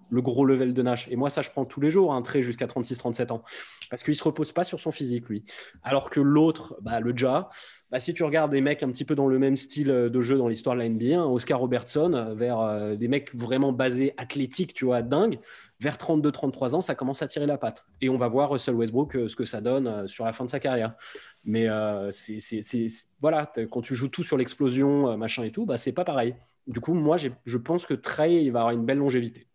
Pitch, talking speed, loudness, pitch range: 130 Hz, 260 wpm, -26 LUFS, 120-145 Hz